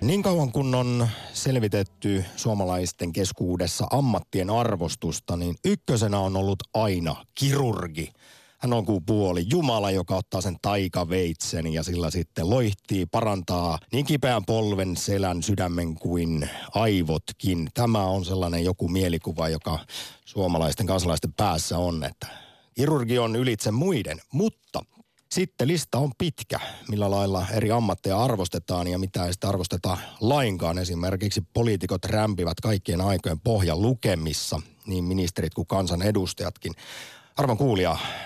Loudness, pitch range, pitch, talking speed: -26 LUFS, 90-115 Hz, 95 Hz, 125 wpm